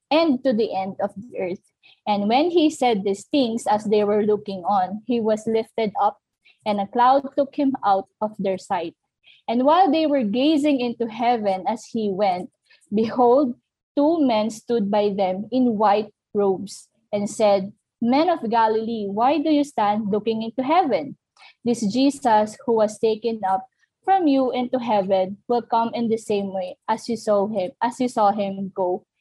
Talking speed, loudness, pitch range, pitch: 180 wpm, -22 LUFS, 205-255 Hz, 225 Hz